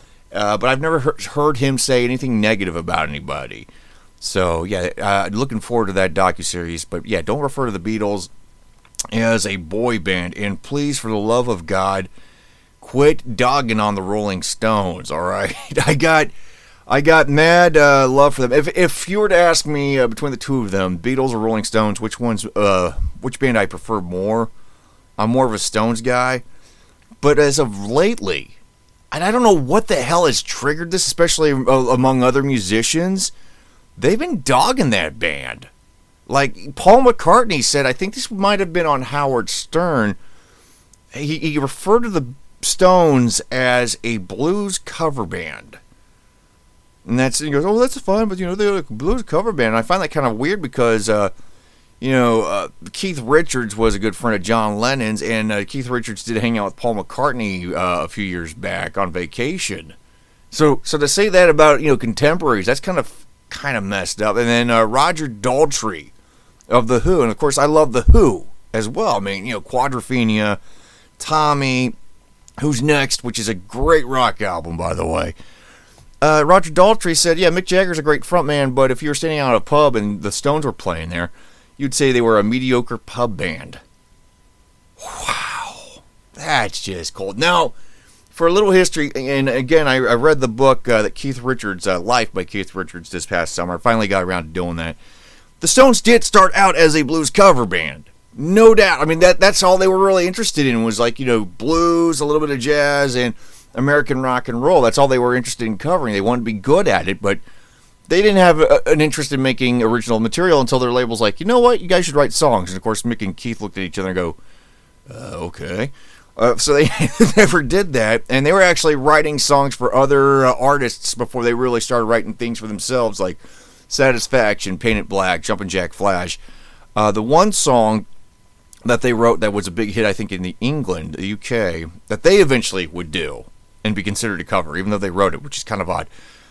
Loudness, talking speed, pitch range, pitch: -17 LUFS, 205 wpm, 105-150 Hz, 125 Hz